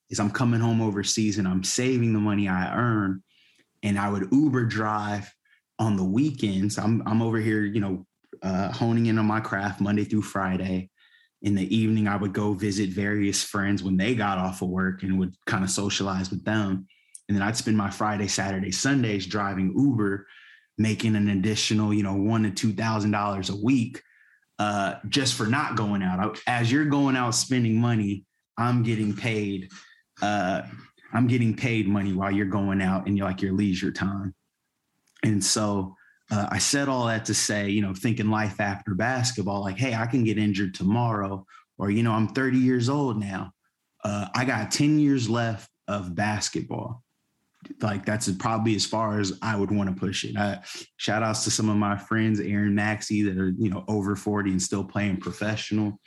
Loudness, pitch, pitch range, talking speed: -25 LUFS, 105 Hz, 100-110 Hz, 190 wpm